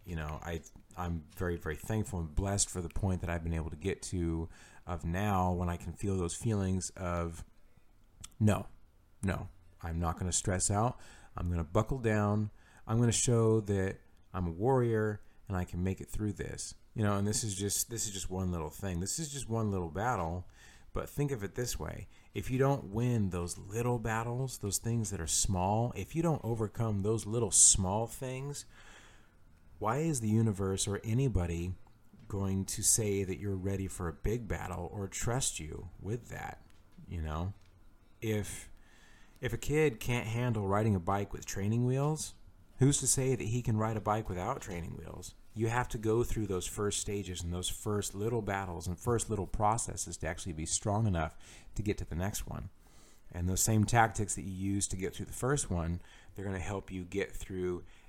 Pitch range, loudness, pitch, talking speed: 90-110 Hz, -34 LUFS, 100 Hz, 200 wpm